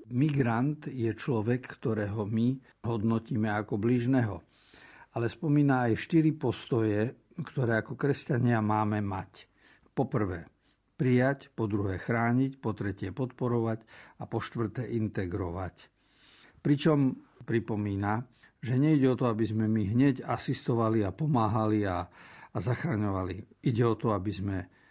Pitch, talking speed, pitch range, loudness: 115 Hz, 125 wpm, 110-130 Hz, -30 LUFS